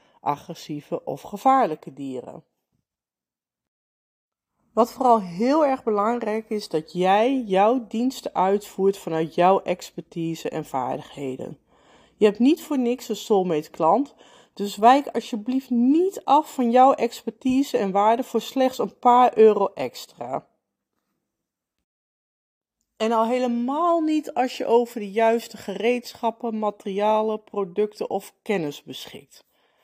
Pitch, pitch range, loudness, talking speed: 220 Hz, 195-245 Hz, -22 LUFS, 120 wpm